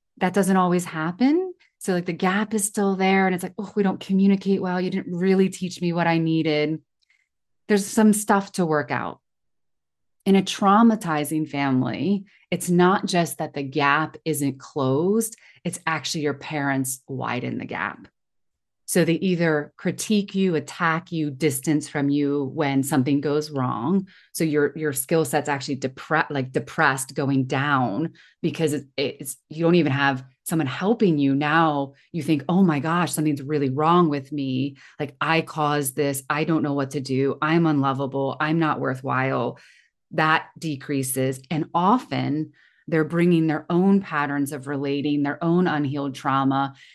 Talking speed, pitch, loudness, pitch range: 165 wpm, 155 Hz, -23 LUFS, 140-180 Hz